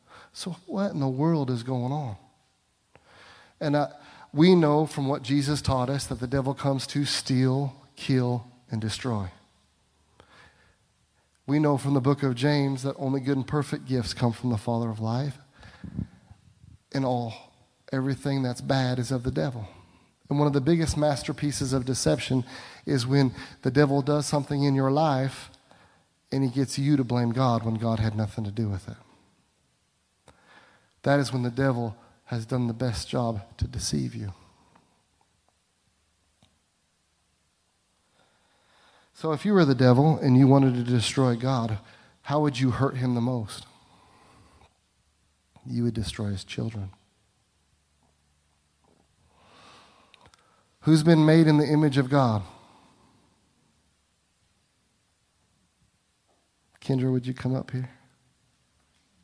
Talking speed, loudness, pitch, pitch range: 140 wpm, -26 LUFS, 125 Hz, 100-140 Hz